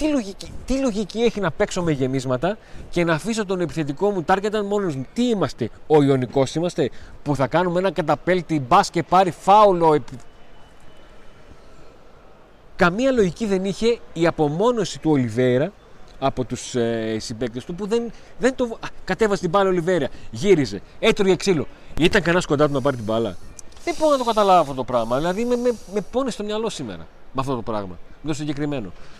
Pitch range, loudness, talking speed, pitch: 135-210 Hz, -21 LUFS, 180 wpm, 175 Hz